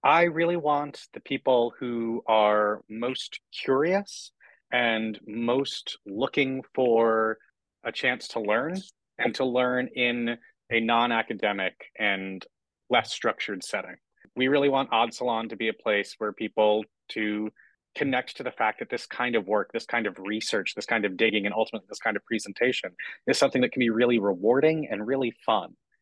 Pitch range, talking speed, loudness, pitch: 110-130 Hz, 165 wpm, -26 LUFS, 115 Hz